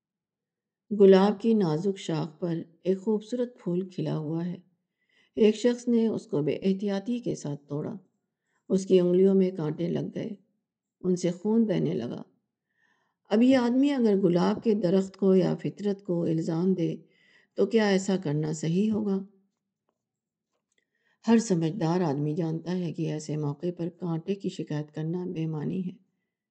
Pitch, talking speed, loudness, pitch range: 190 Hz, 155 wpm, -27 LUFS, 170-205 Hz